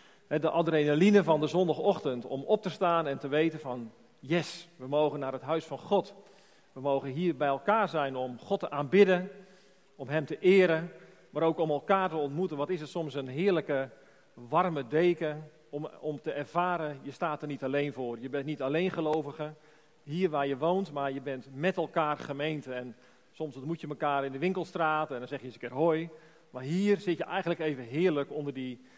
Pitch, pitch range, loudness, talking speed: 155 Hz, 140-175 Hz, -30 LUFS, 205 wpm